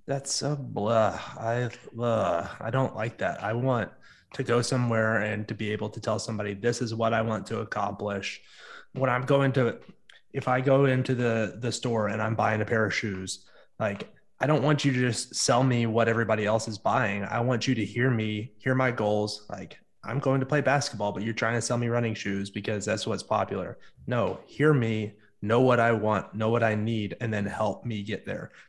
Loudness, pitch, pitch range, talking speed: -27 LUFS, 115 Hz, 105-125 Hz, 220 wpm